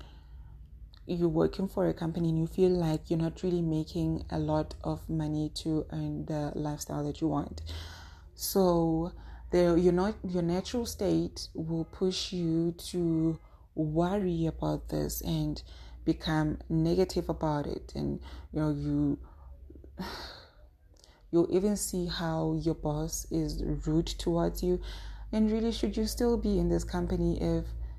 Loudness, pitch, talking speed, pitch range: -31 LUFS, 160 Hz, 145 wpm, 140-175 Hz